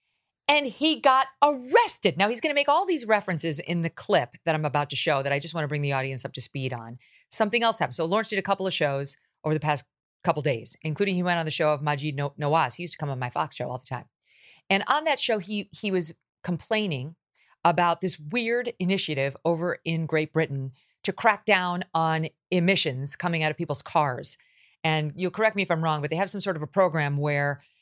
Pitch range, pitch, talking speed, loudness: 150-200 Hz, 165 Hz, 235 wpm, -26 LUFS